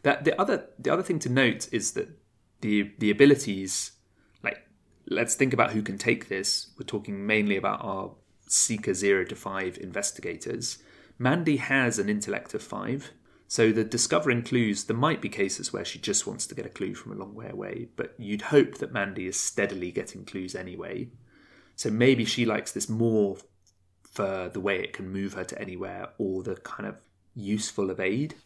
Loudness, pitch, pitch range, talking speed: -27 LUFS, 105 Hz, 95-120 Hz, 190 wpm